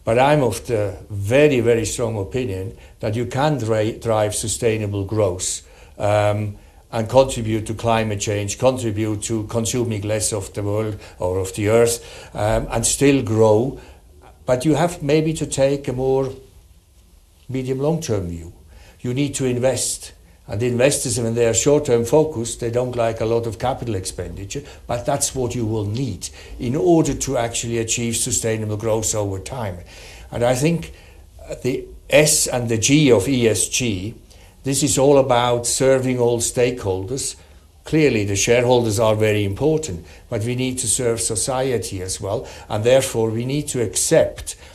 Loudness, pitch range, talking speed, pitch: -19 LUFS, 105-130 Hz, 160 wpm, 115 Hz